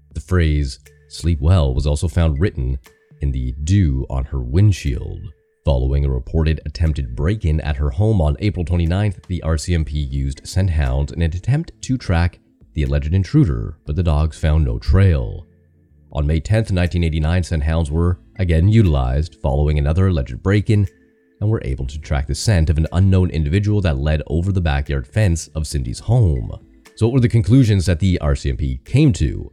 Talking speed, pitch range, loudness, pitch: 180 wpm, 75-95 Hz, -19 LUFS, 80 Hz